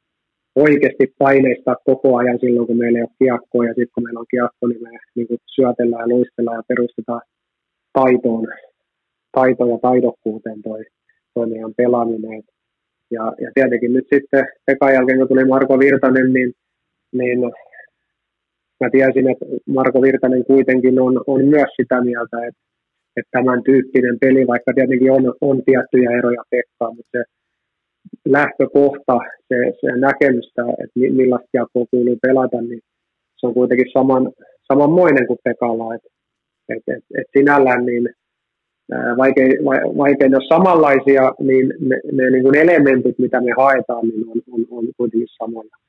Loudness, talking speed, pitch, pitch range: -15 LUFS, 145 wpm, 125 Hz, 120-130 Hz